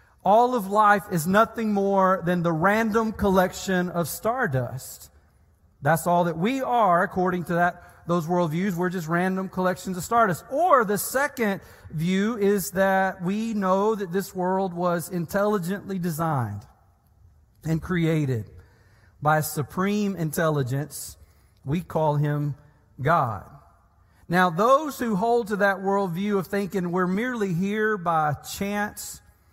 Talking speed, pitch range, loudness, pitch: 135 wpm, 145-200 Hz, -24 LUFS, 180 Hz